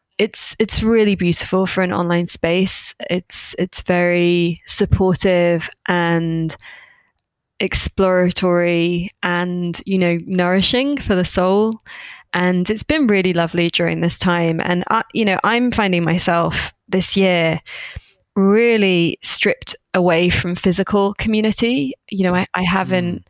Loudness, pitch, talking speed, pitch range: -17 LUFS, 180 Hz, 125 wpm, 175-200 Hz